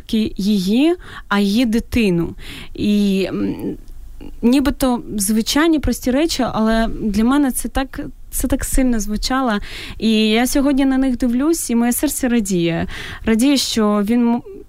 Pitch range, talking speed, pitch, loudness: 215-270 Hz, 125 wpm, 240 Hz, -17 LUFS